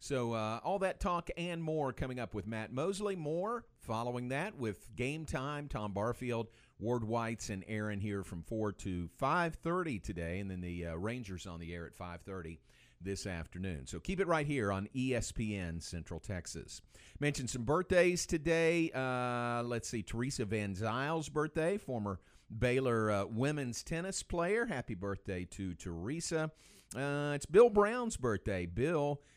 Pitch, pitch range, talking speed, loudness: 120 Hz, 100-150 Hz, 160 wpm, -36 LUFS